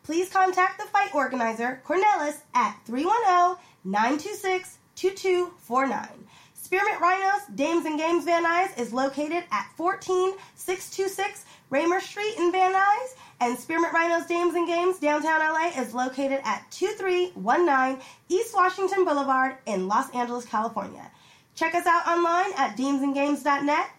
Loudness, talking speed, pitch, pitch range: -25 LUFS, 125 wpm, 335 Hz, 270-370 Hz